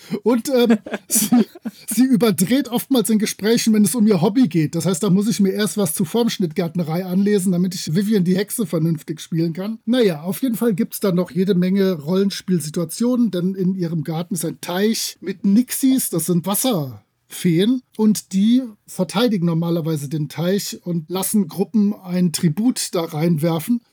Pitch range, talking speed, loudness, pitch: 175-225 Hz, 175 wpm, -19 LUFS, 195 Hz